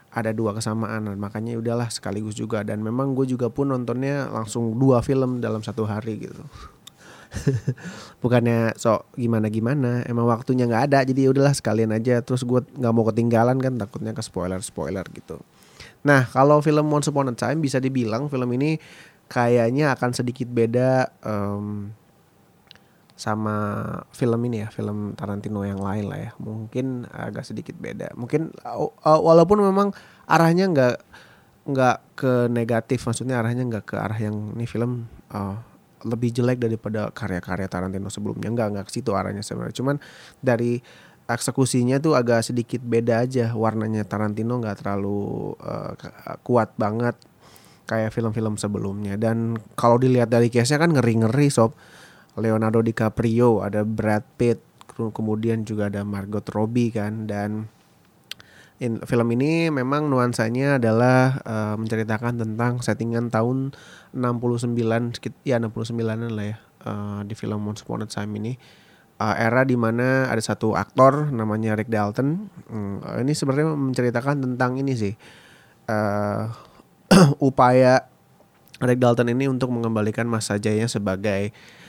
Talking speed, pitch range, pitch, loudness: 140 wpm, 110-130 Hz, 115 Hz, -23 LUFS